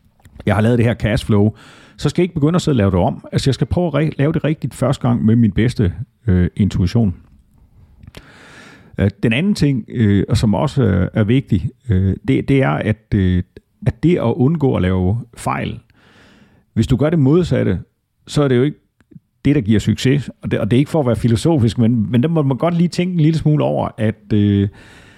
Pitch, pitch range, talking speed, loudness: 115 Hz, 105-145 Hz, 220 wpm, -17 LUFS